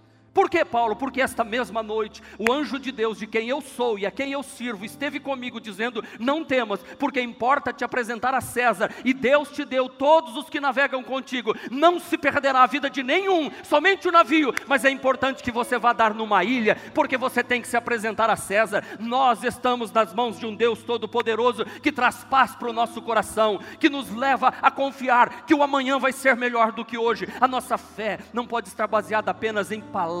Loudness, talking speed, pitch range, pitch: -23 LUFS, 210 wpm, 225-275 Hz, 245 Hz